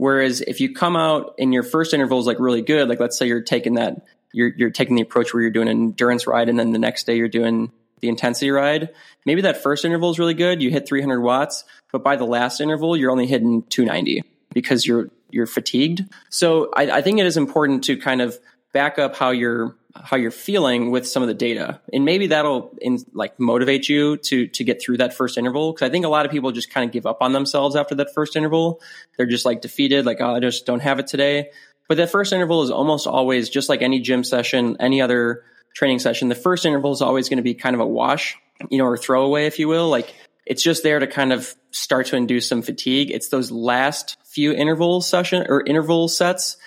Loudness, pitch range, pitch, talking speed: -19 LUFS, 120-155 Hz, 135 Hz, 240 wpm